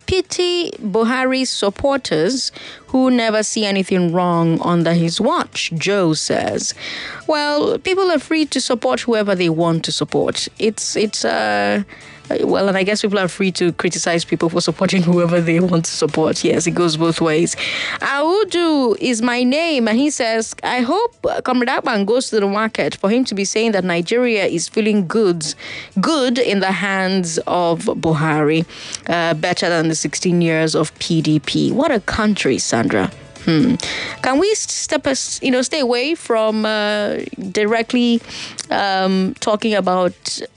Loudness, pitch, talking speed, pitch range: -17 LUFS, 205 Hz, 160 wpm, 170-250 Hz